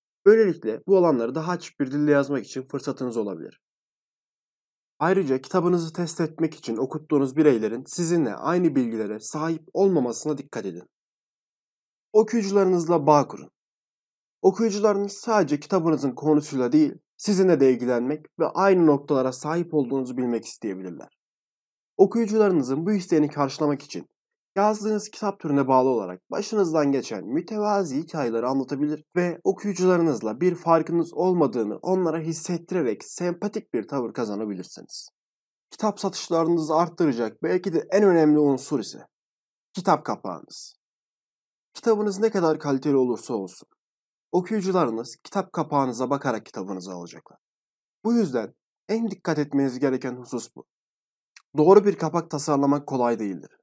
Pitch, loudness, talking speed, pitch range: 160 Hz, -24 LUFS, 120 wpm, 135-190 Hz